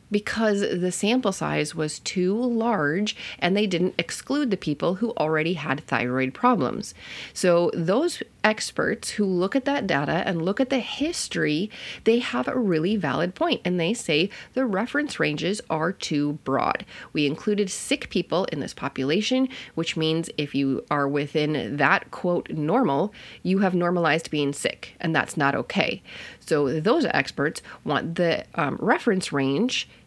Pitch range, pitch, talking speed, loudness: 155-220 Hz, 180 Hz, 160 wpm, -24 LUFS